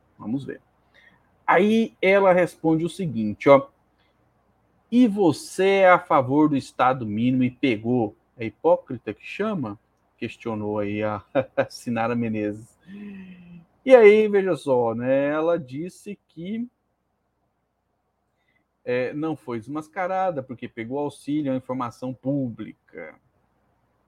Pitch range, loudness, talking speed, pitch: 120-180 Hz, -22 LUFS, 115 wpm, 140 Hz